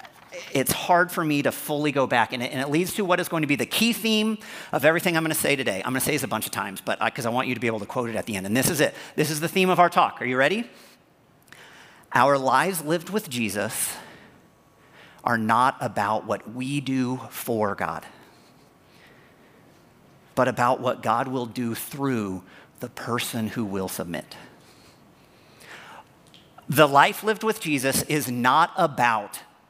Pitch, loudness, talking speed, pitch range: 140 Hz, -24 LUFS, 200 wpm, 125-175 Hz